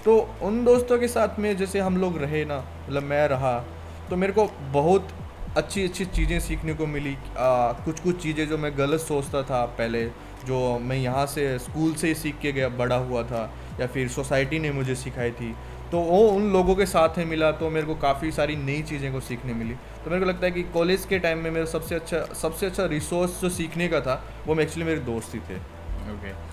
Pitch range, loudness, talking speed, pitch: 130-175 Hz, -25 LUFS, 225 wpm, 155 Hz